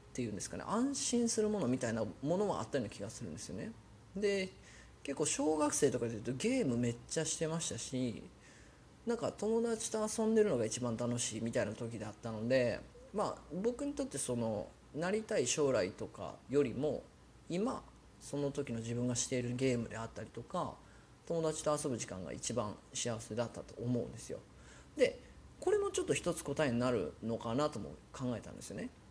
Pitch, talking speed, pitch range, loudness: 130 Hz, 375 characters per minute, 115-180 Hz, -37 LUFS